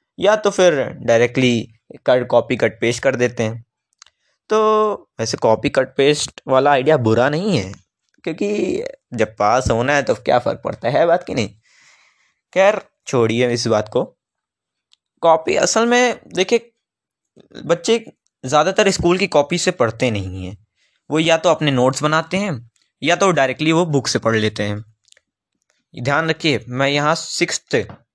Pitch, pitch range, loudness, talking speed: 145 Hz, 120-185 Hz, -17 LUFS, 155 wpm